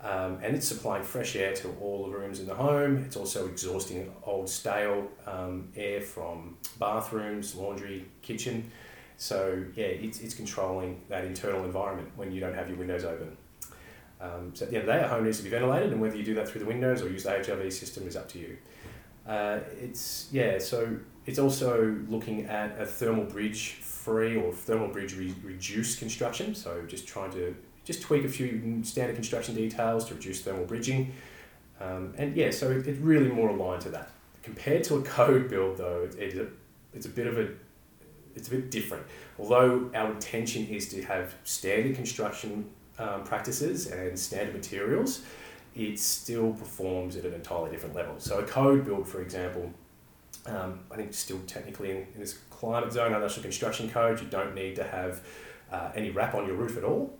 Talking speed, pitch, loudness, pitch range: 195 wpm, 105 Hz, -31 LUFS, 95-115 Hz